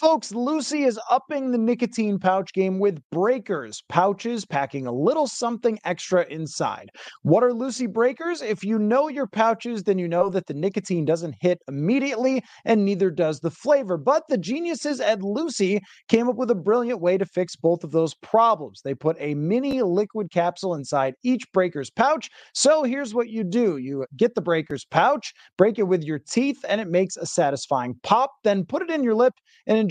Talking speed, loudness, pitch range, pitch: 195 wpm, -23 LUFS, 175-250 Hz, 210 Hz